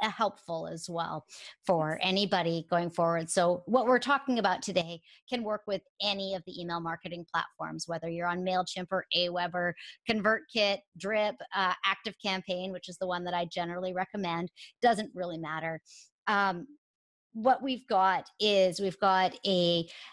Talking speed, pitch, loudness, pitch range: 155 wpm, 185 Hz, -31 LUFS, 175-205 Hz